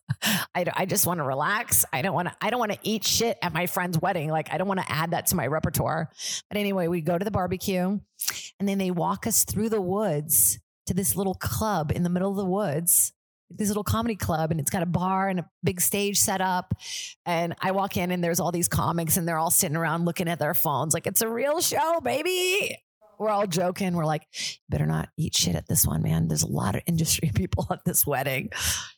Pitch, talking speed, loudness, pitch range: 180 Hz, 240 wpm, -25 LUFS, 160-200 Hz